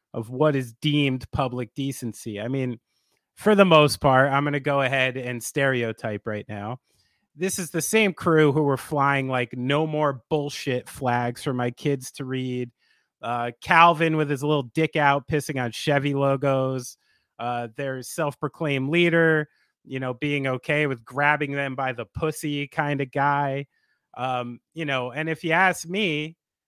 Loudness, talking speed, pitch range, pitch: -24 LUFS, 170 wpm, 125-150 Hz, 140 Hz